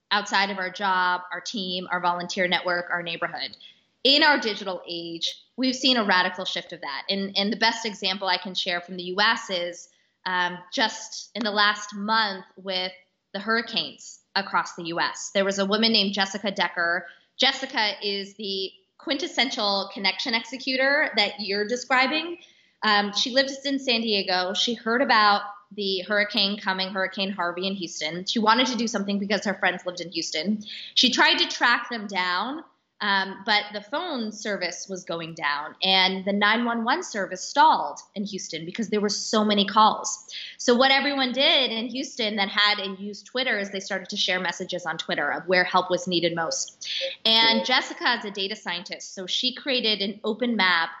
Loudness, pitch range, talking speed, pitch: -24 LUFS, 185-230 Hz, 180 wpm, 200 Hz